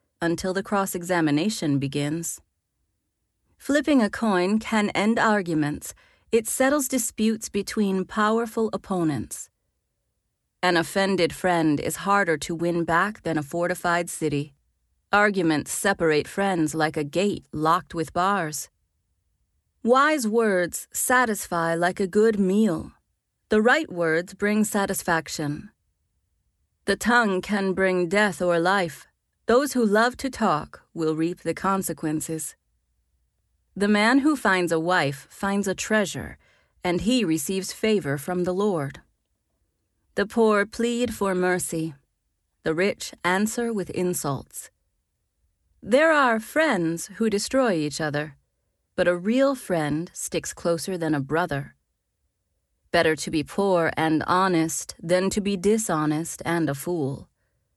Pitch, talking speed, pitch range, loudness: 180 Hz, 125 wpm, 155-210 Hz, -24 LUFS